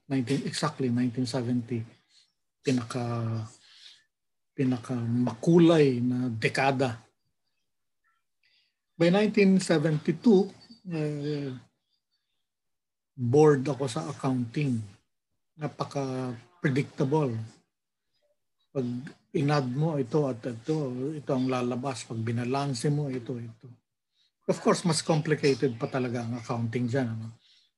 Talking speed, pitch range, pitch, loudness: 90 wpm, 125-155 Hz, 135 Hz, -28 LUFS